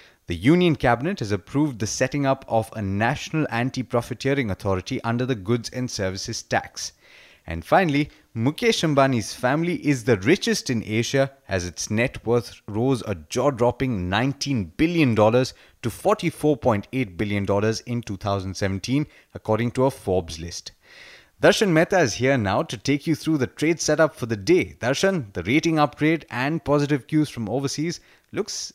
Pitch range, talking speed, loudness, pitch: 110-150 Hz, 155 wpm, -23 LUFS, 125 Hz